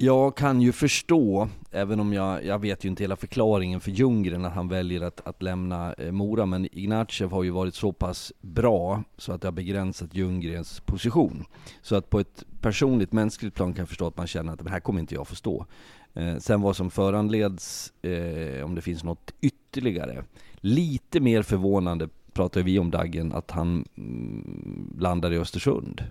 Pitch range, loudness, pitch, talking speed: 90-105 Hz, -27 LUFS, 95 Hz, 190 wpm